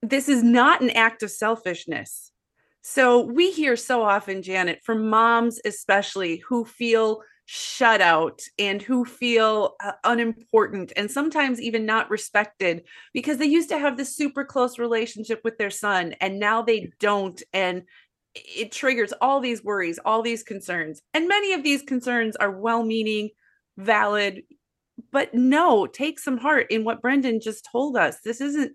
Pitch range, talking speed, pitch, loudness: 210-265 Hz, 160 wpm, 230 Hz, -22 LUFS